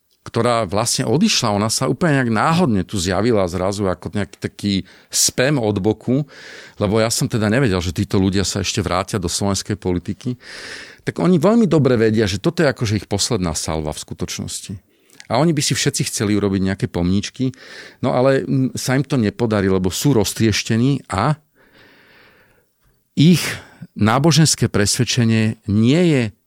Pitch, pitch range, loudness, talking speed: 115 Hz, 100-135 Hz, -18 LUFS, 155 wpm